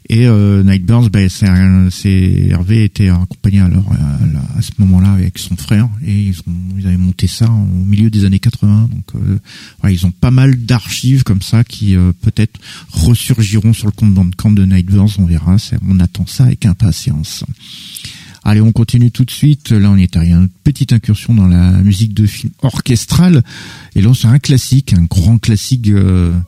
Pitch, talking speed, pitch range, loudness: 105 Hz, 210 wpm, 95-115 Hz, -11 LUFS